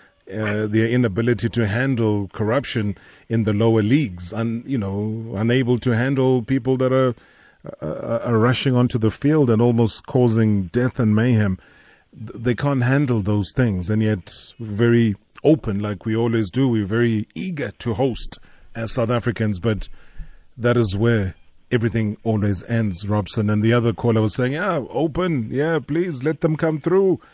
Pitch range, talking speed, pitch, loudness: 110-130 Hz, 165 wpm, 115 Hz, -20 LUFS